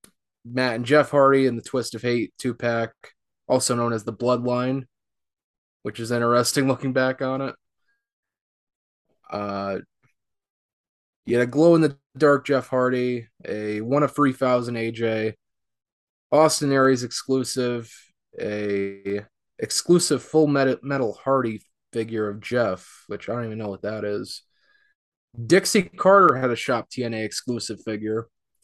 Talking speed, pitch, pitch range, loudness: 120 wpm, 125 Hz, 110-135 Hz, -23 LUFS